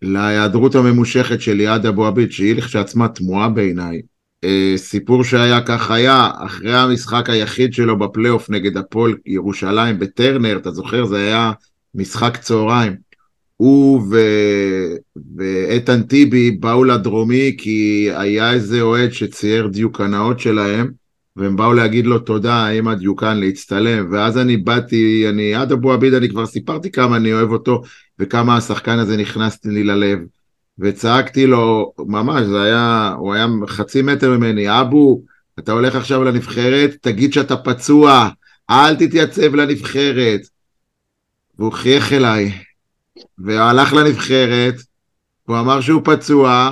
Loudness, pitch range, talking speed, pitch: -14 LUFS, 105-125 Hz, 130 wpm, 115 Hz